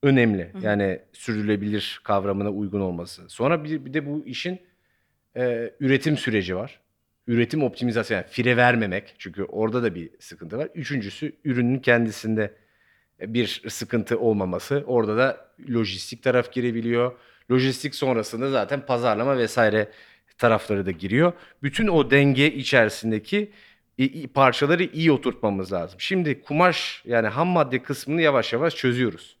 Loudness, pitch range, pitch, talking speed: -23 LUFS, 110-140 Hz, 125 Hz, 130 wpm